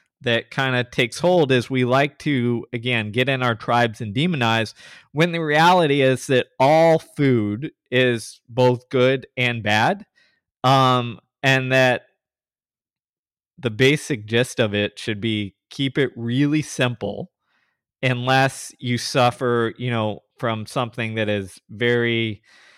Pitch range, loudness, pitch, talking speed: 115-135 Hz, -20 LUFS, 125 Hz, 135 wpm